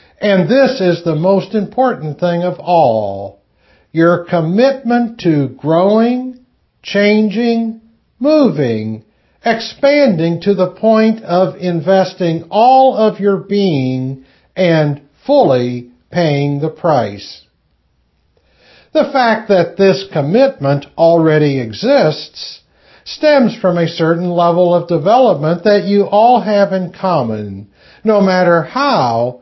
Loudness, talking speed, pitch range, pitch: -13 LUFS, 110 wpm, 150-220 Hz, 180 Hz